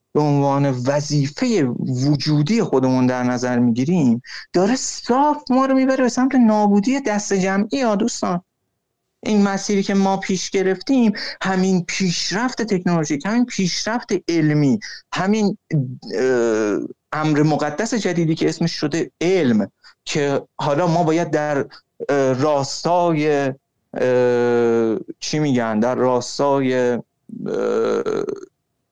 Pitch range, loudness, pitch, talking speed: 140-210 Hz, -19 LUFS, 170 Hz, 105 wpm